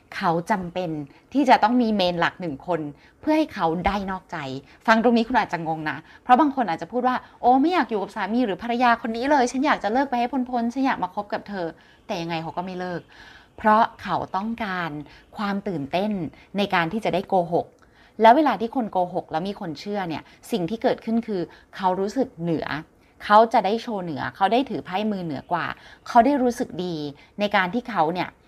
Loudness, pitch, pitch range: -23 LUFS, 200 Hz, 170-240 Hz